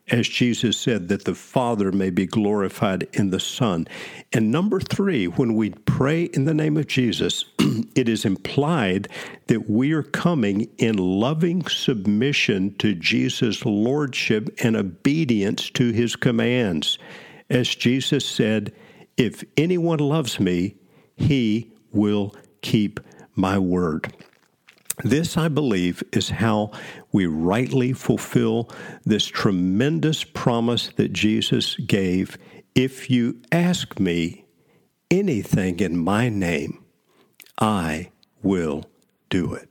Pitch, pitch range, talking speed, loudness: 120 Hz, 105-140 Hz, 120 wpm, -22 LUFS